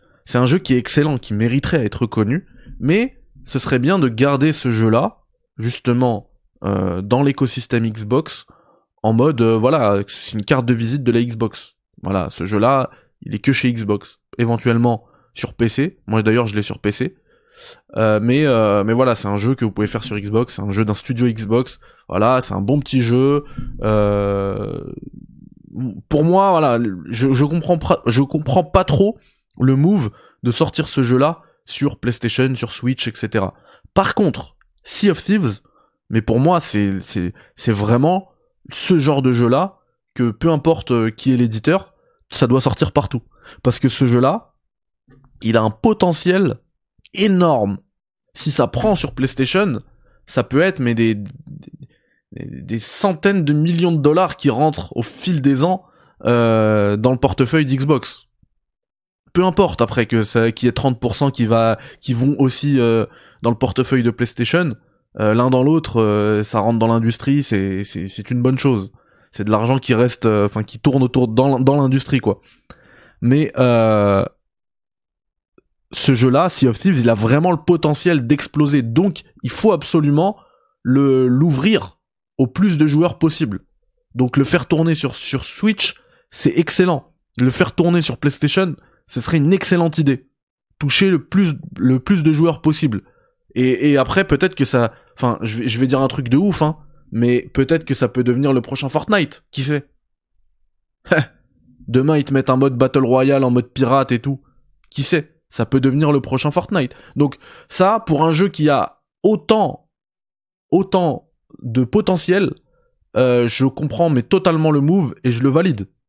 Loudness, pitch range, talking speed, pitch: -17 LUFS, 120-160 Hz, 175 wpm, 135 Hz